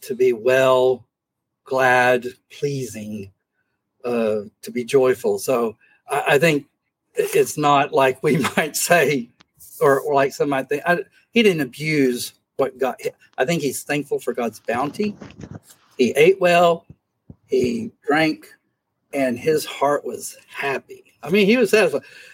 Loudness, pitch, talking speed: -20 LUFS, 145 Hz, 140 wpm